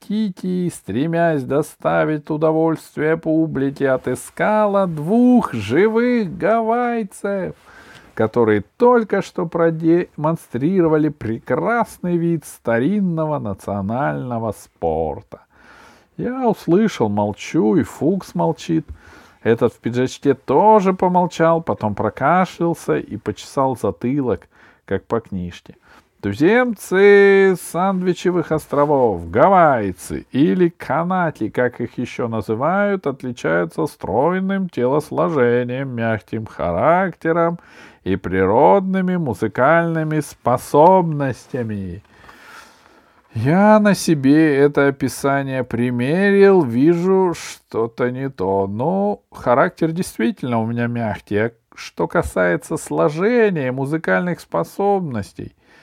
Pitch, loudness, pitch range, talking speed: 155 Hz, -18 LUFS, 120-185 Hz, 85 wpm